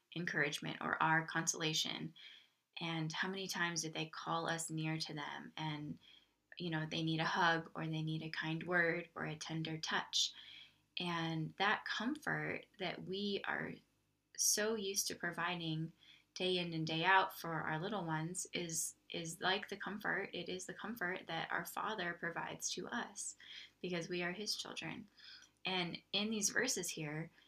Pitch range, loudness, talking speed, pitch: 160-185 Hz, -39 LUFS, 165 wpm, 165 Hz